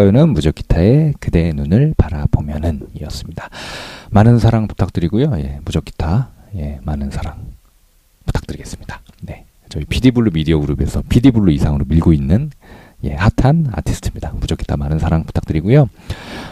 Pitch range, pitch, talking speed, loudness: 75-115 Hz, 85 Hz, 360 characters per minute, -16 LUFS